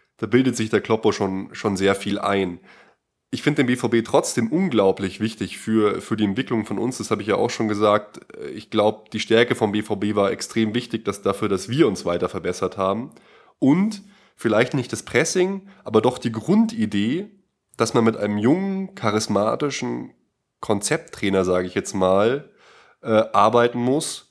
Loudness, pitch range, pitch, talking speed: -21 LUFS, 100-125 Hz, 110 Hz, 175 wpm